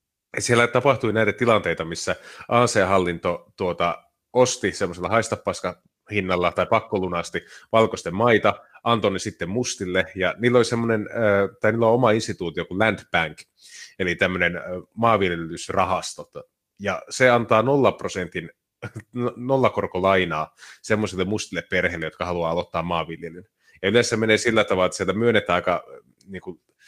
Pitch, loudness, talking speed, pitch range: 105 Hz, -22 LUFS, 120 wpm, 90-115 Hz